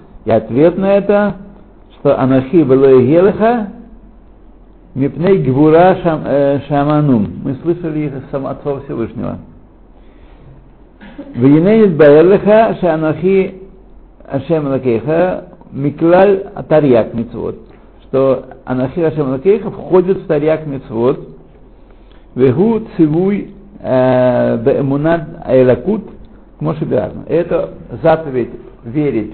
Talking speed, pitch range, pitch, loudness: 85 wpm, 135-190 Hz, 155 Hz, -13 LUFS